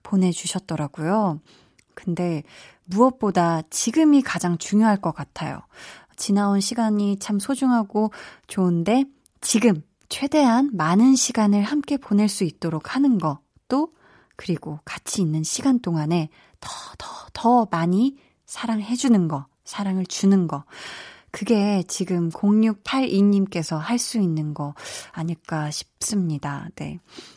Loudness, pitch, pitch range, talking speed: -22 LUFS, 195 Hz, 170-235 Hz, 245 characters per minute